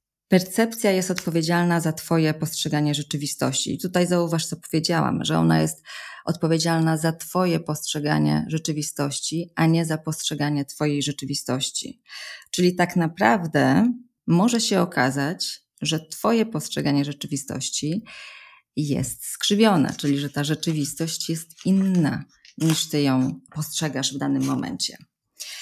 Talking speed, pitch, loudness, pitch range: 120 wpm, 160 Hz, -23 LUFS, 145-180 Hz